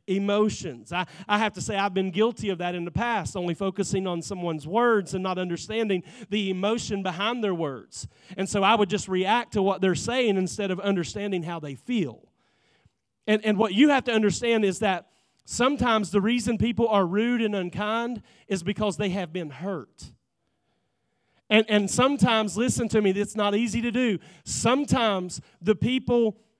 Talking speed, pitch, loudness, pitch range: 180 wpm, 205 Hz, -25 LUFS, 185-225 Hz